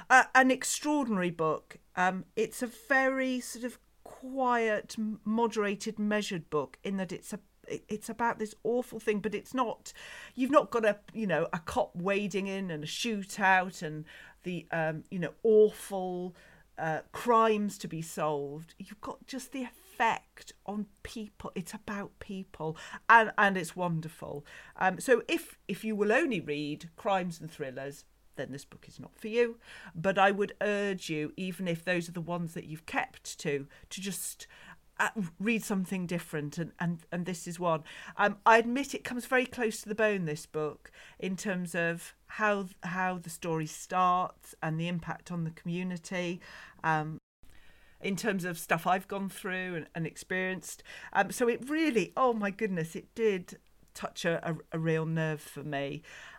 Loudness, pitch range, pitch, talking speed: -31 LUFS, 165-215 Hz, 190 Hz, 170 wpm